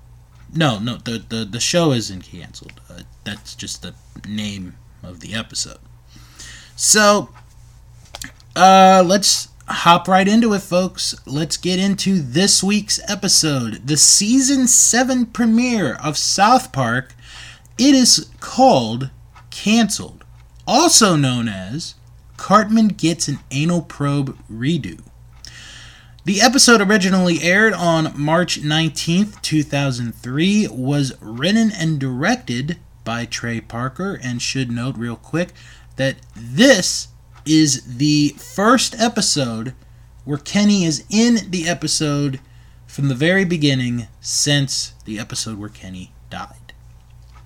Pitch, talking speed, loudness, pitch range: 140 Hz, 115 wpm, -16 LUFS, 120-185 Hz